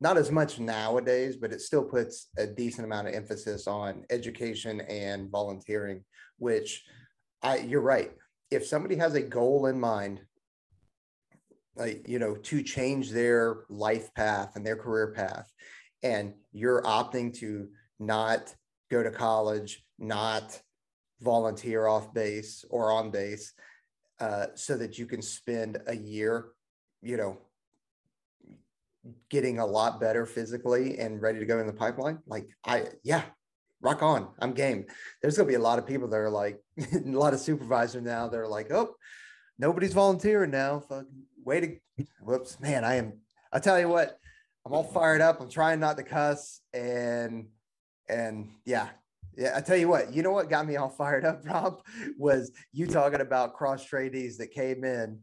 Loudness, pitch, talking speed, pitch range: -30 LUFS, 120 Hz, 165 wpm, 110-140 Hz